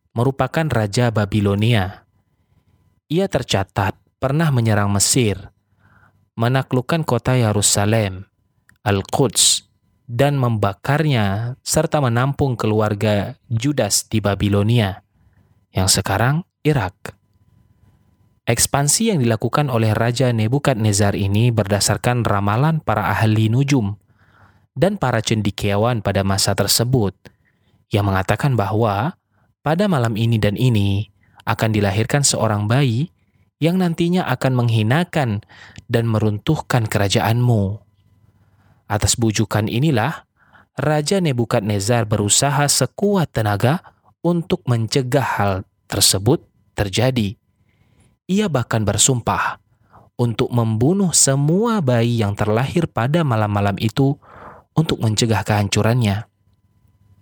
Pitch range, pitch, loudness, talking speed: 100-130 Hz, 110 Hz, -18 LUFS, 90 wpm